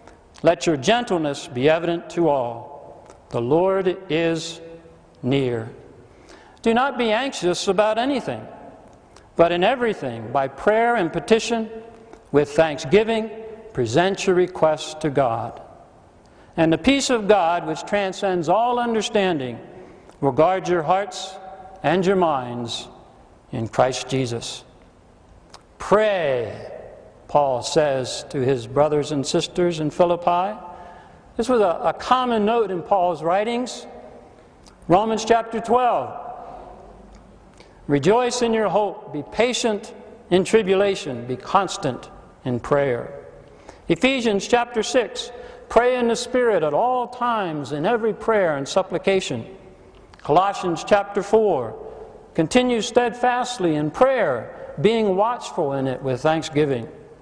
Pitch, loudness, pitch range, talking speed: 185 Hz, -21 LUFS, 150-225 Hz, 115 wpm